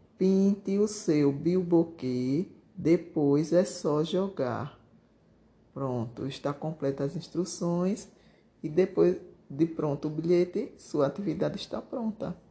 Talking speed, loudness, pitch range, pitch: 110 wpm, -29 LUFS, 145-185 Hz, 170 Hz